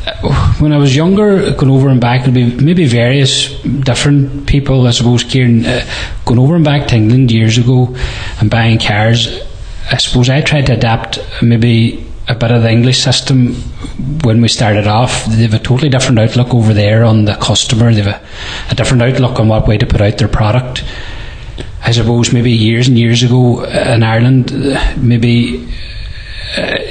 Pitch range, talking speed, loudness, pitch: 110-130 Hz, 180 wpm, -10 LUFS, 120 Hz